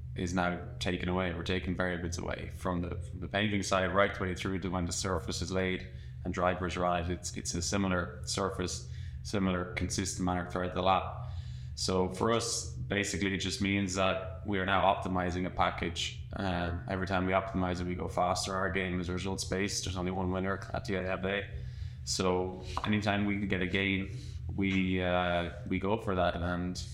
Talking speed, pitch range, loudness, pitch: 200 wpm, 90-100 Hz, -33 LUFS, 95 Hz